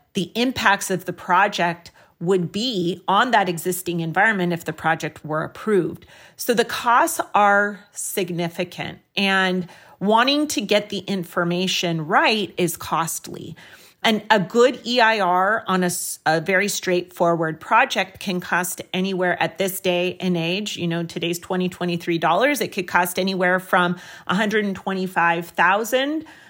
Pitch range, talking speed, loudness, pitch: 175-205 Hz, 135 wpm, -21 LUFS, 185 Hz